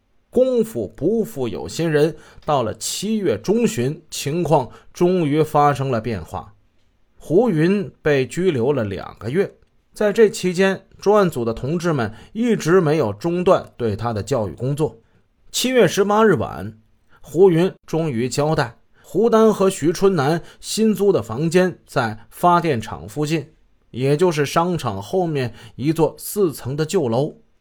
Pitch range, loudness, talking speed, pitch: 115-185 Hz, -19 LUFS, 215 characters per minute, 155 Hz